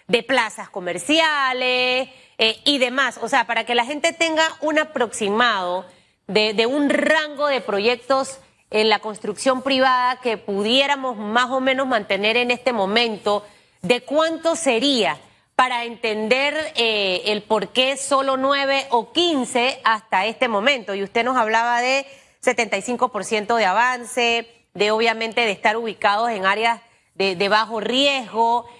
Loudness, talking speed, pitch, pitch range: -19 LUFS, 145 wpm, 240 Hz, 215-265 Hz